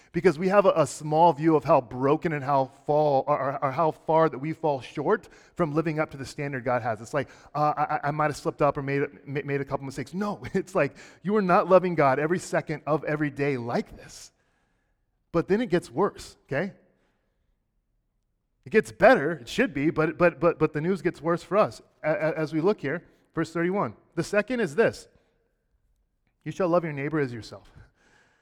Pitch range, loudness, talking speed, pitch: 140-175 Hz, -26 LUFS, 210 wpm, 155 Hz